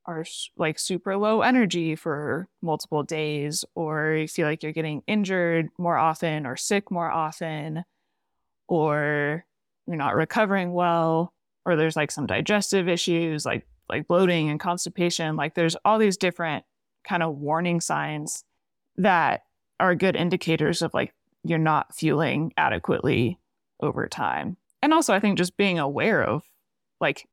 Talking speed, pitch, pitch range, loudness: 145 wpm, 165 Hz, 155-180 Hz, -25 LUFS